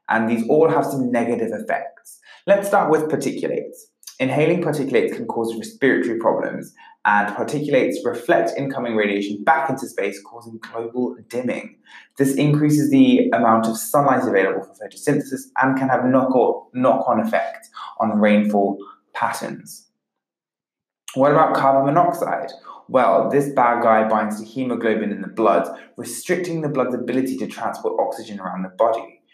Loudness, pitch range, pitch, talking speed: -20 LUFS, 110-150 Hz, 130 Hz, 145 wpm